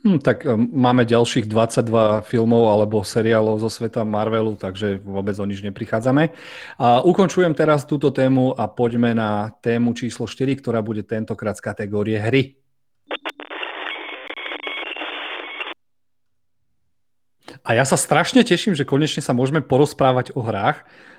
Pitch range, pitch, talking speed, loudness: 110-135 Hz, 120 Hz, 125 wpm, -20 LUFS